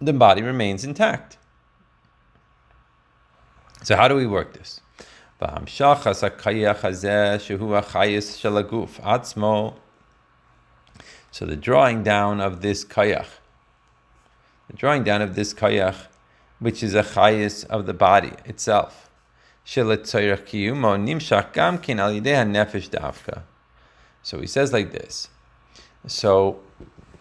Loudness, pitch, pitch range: -21 LUFS, 105 Hz, 90-110 Hz